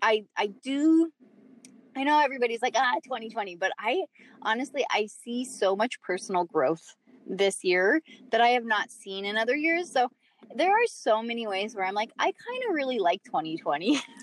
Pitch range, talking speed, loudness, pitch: 205-270 Hz, 180 wpm, -27 LUFS, 240 Hz